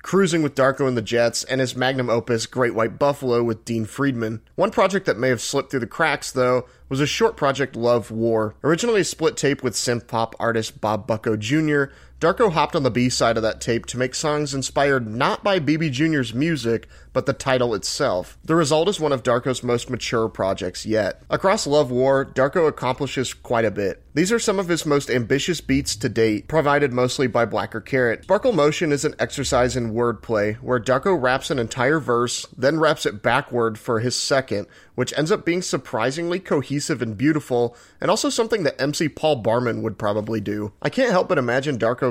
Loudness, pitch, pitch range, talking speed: -21 LUFS, 130 Hz, 115-150 Hz, 200 wpm